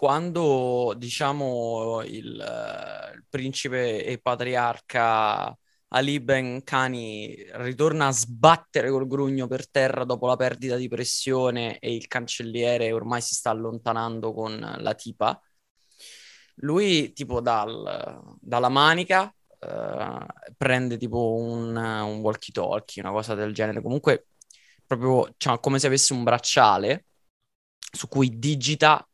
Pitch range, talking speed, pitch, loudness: 115-135 Hz, 120 wpm, 125 Hz, -25 LUFS